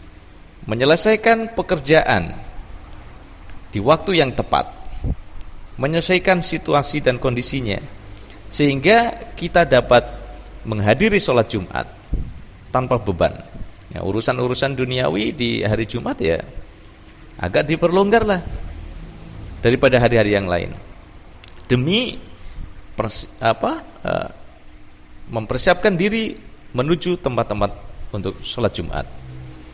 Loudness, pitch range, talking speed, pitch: -18 LUFS, 95-155 Hz, 85 wpm, 115 Hz